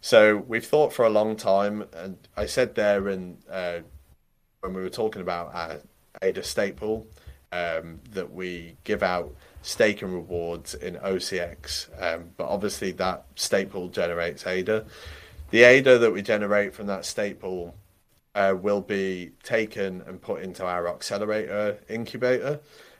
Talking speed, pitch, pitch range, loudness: 145 wpm, 95 Hz, 85-105 Hz, -25 LUFS